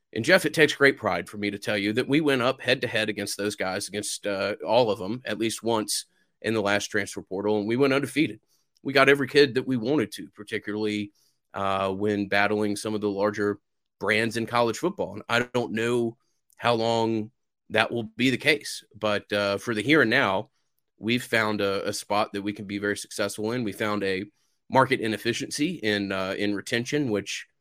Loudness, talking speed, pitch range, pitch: -25 LUFS, 215 wpm, 105-125 Hz, 110 Hz